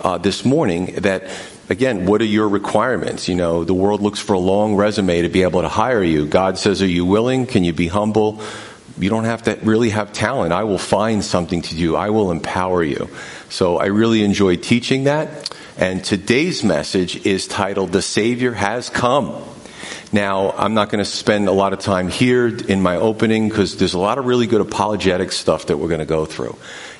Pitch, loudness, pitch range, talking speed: 100 Hz, -17 LUFS, 90-110 Hz, 210 wpm